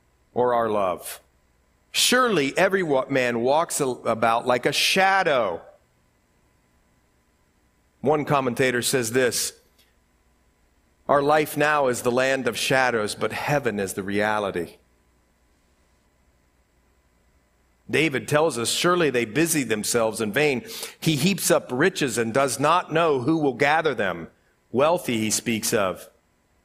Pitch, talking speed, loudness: 115 Hz, 120 wpm, -22 LUFS